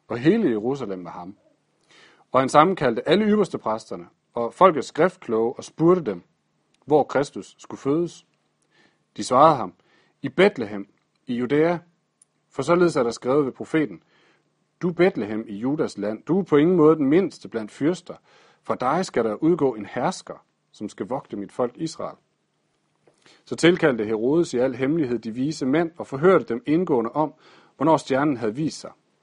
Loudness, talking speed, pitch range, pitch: -22 LUFS, 165 wpm, 120-170 Hz, 145 Hz